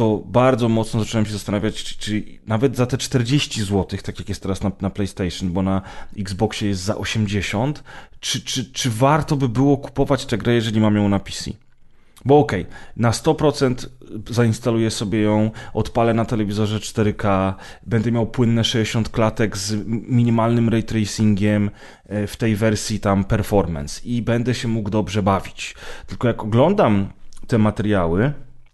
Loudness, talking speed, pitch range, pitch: -20 LUFS, 160 wpm, 100-120 Hz, 110 Hz